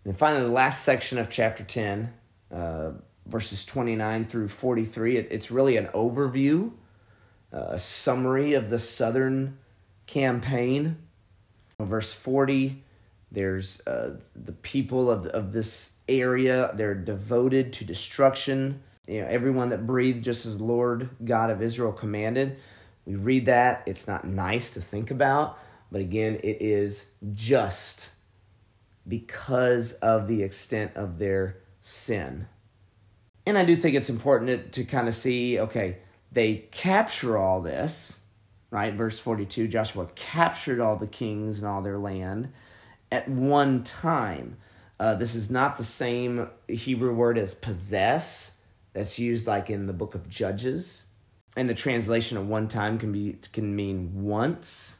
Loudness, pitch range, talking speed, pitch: -27 LUFS, 100-125 Hz, 145 wpm, 110 Hz